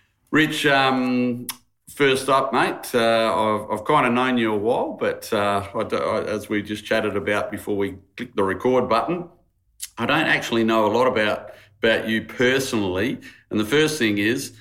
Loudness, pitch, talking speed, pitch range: -21 LUFS, 115 Hz, 180 wpm, 105-130 Hz